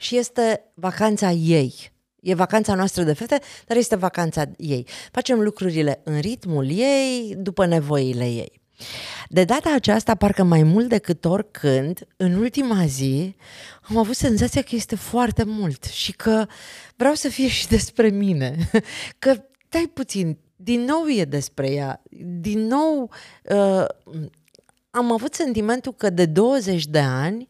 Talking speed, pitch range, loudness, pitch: 145 wpm, 160-240 Hz, -21 LUFS, 200 Hz